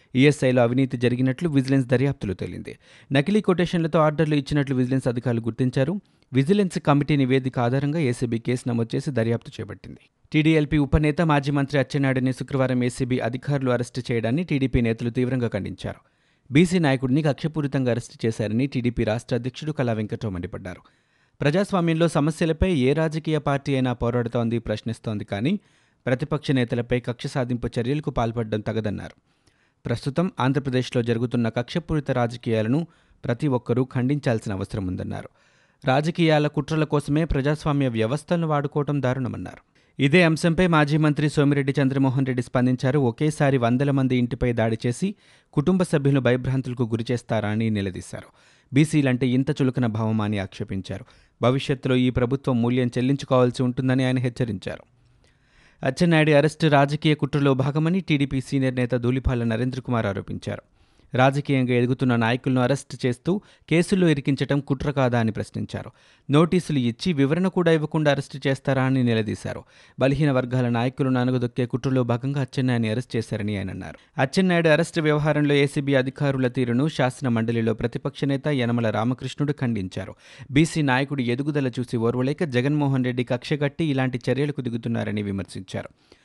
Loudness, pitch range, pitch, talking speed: -23 LUFS, 120-145 Hz, 130 Hz, 125 wpm